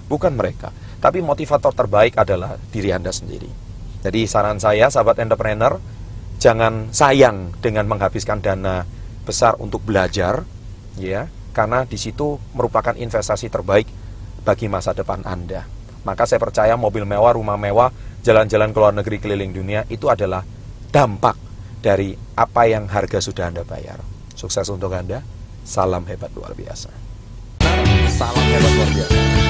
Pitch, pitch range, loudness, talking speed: 105 Hz, 95-110 Hz, -18 LUFS, 135 wpm